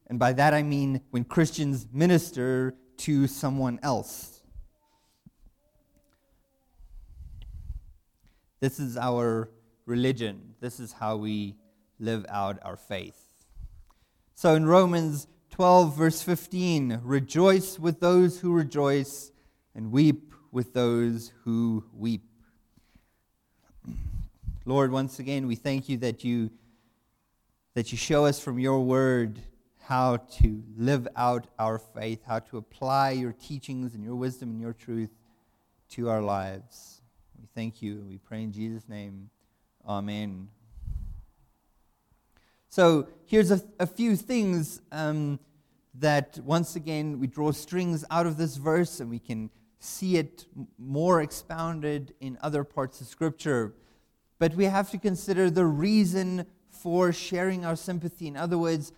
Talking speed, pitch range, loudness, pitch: 130 wpm, 115-160 Hz, -27 LUFS, 130 Hz